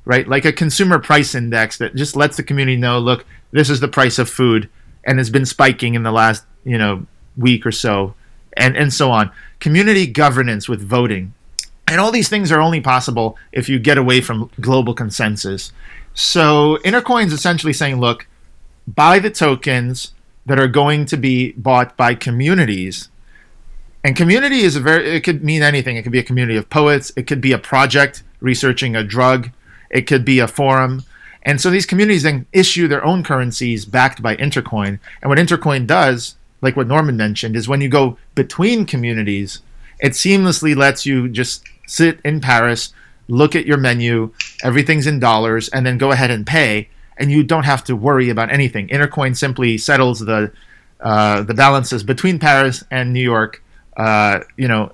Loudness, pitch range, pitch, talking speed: -15 LUFS, 115-145 Hz, 130 Hz, 185 wpm